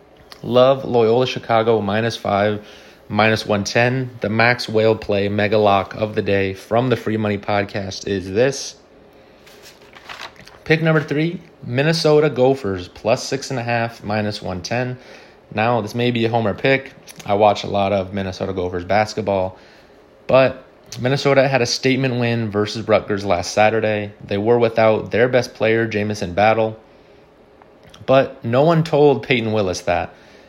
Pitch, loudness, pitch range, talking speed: 110 Hz, -18 LUFS, 105-125 Hz, 140 wpm